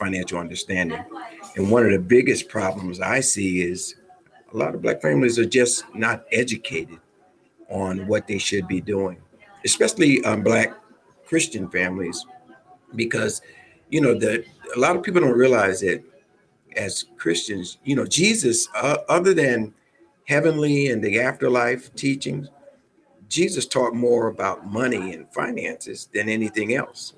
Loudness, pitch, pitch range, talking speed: -22 LUFS, 120 Hz, 95-140 Hz, 145 wpm